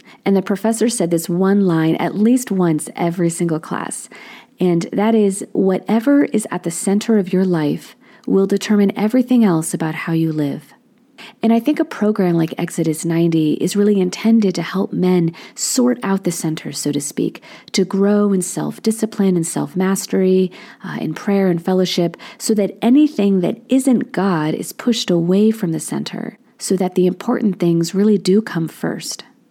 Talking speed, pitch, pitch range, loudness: 175 wpm, 195 Hz, 175-220 Hz, -17 LUFS